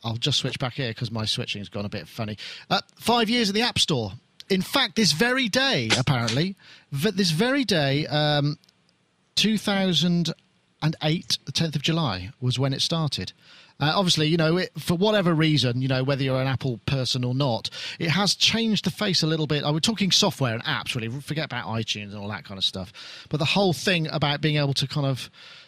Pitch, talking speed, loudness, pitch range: 150 Hz, 210 wpm, -24 LUFS, 130-180 Hz